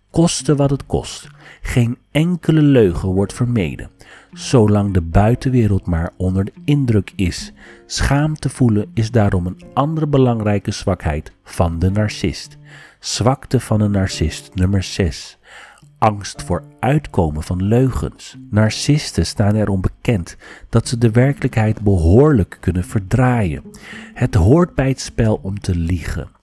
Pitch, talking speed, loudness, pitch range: 110 Hz, 135 wpm, -17 LUFS, 95-135 Hz